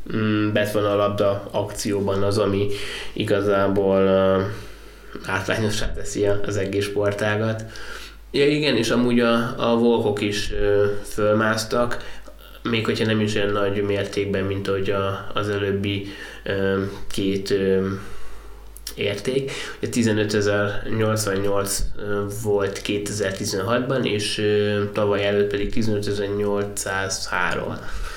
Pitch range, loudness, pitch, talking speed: 100-105 Hz, -22 LUFS, 100 Hz, 100 wpm